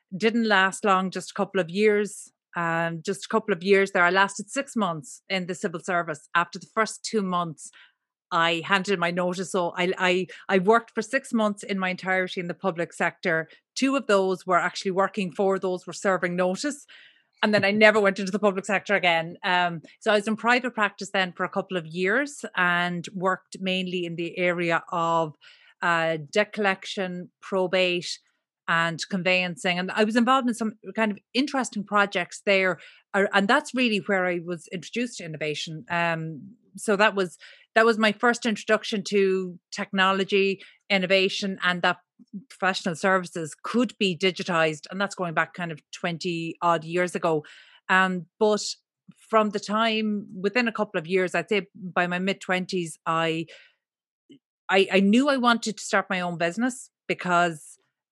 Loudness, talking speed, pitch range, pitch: -25 LUFS, 180 wpm, 180-210 Hz, 190 Hz